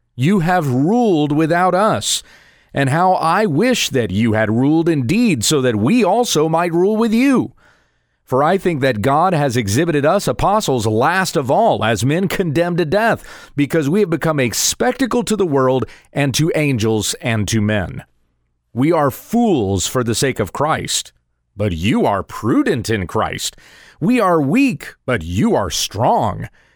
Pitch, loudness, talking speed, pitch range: 150 Hz, -16 LUFS, 170 wpm, 115-185 Hz